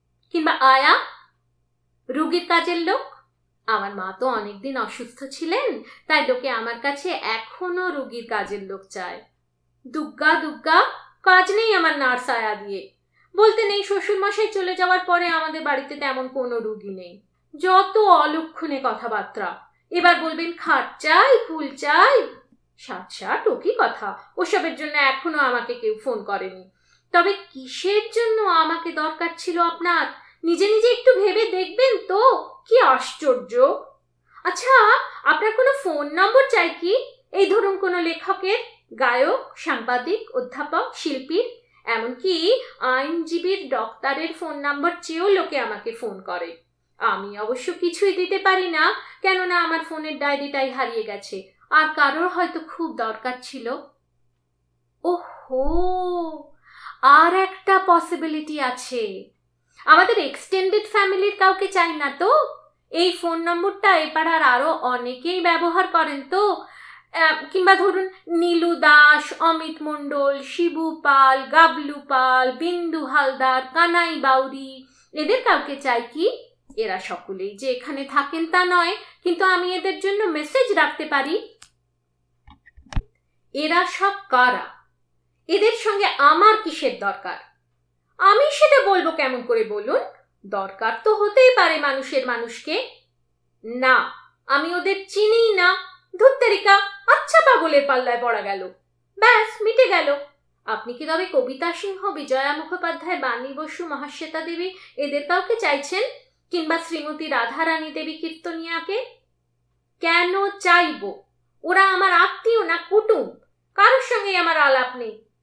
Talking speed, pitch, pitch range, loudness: 115 wpm, 330 Hz, 270-385 Hz, -20 LUFS